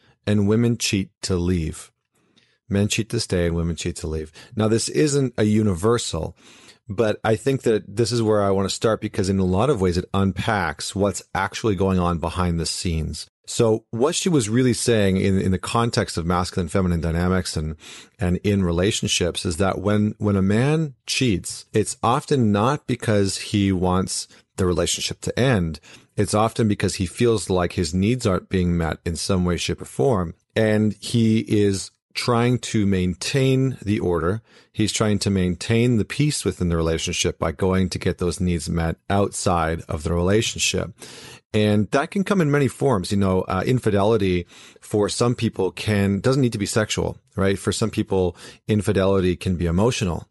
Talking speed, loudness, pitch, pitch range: 185 wpm, -22 LUFS, 100 Hz, 90-115 Hz